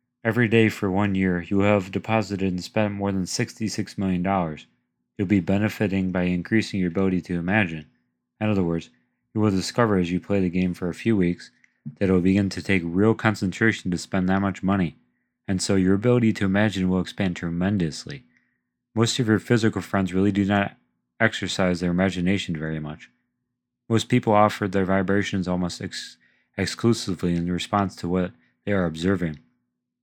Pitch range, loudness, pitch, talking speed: 90-105 Hz, -23 LUFS, 95 Hz, 180 wpm